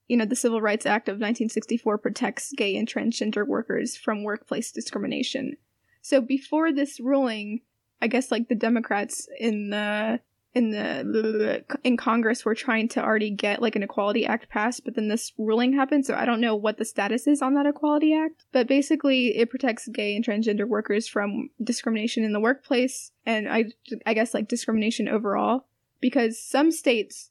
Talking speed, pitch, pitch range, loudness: 180 wpm, 230 Hz, 220-260 Hz, -25 LUFS